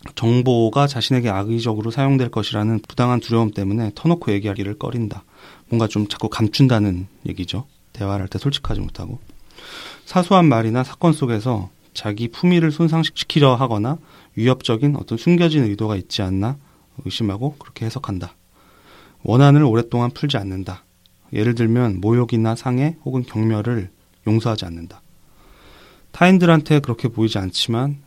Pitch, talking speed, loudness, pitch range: 115 Hz, 345 characters per minute, -19 LUFS, 105-135 Hz